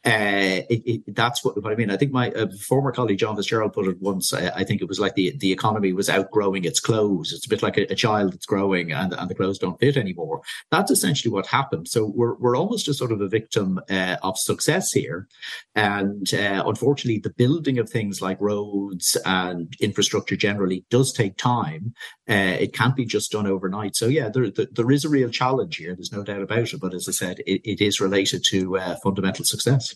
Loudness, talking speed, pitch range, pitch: -22 LUFS, 230 wpm, 95-120 Hz, 105 Hz